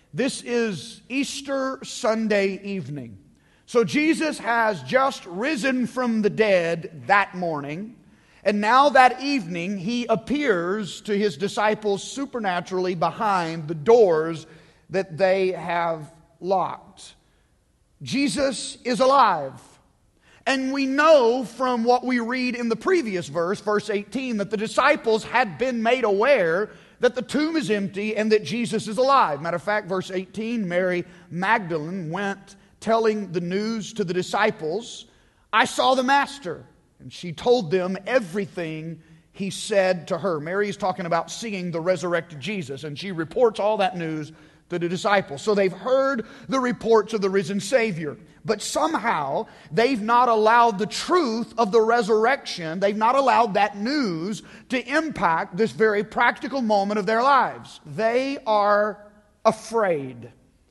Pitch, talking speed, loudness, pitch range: 210 Hz, 145 wpm, -23 LUFS, 180-240 Hz